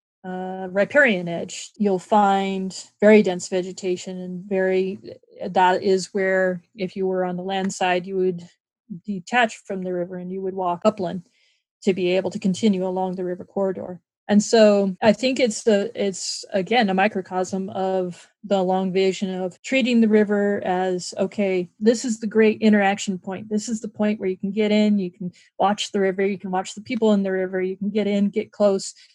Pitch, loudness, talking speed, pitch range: 195 Hz, -22 LUFS, 195 wpm, 185-210 Hz